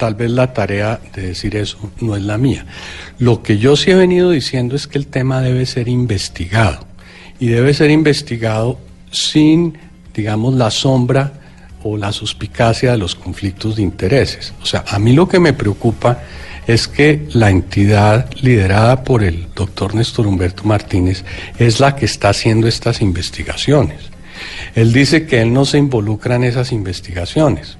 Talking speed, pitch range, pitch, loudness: 165 wpm, 100-130 Hz, 115 Hz, -14 LUFS